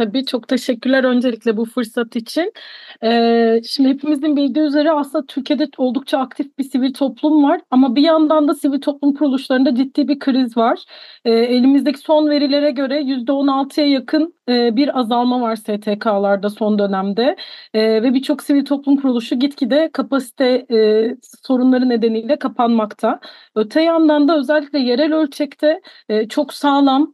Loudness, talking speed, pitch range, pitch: -16 LUFS, 145 wpm, 240-295 Hz, 270 Hz